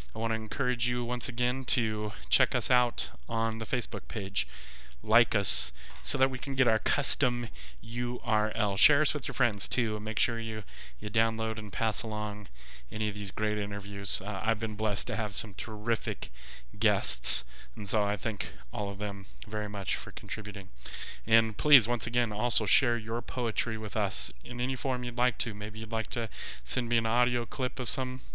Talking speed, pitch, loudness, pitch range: 195 wpm, 110 Hz, -24 LUFS, 105-120 Hz